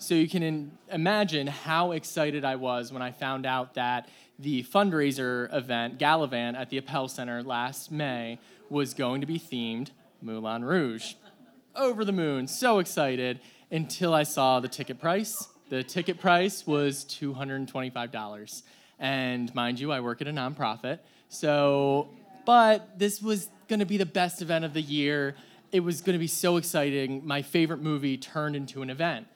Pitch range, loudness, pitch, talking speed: 130-175 Hz, -28 LUFS, 145 Hz, 165 wpm